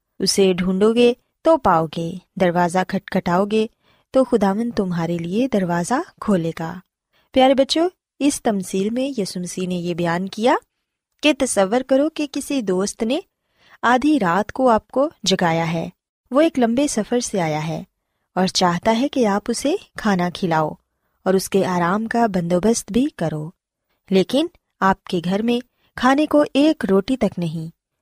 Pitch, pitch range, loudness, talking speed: 205 Hz, 180-255 Hz, -20 LUFS, 160 wpm